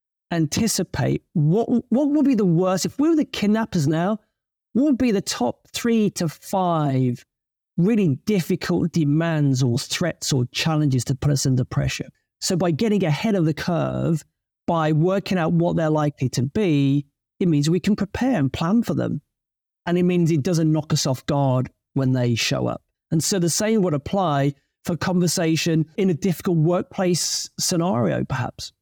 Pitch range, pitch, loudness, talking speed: 145-190 Hz, 165 Hz, -21 LUFS, 175 wpm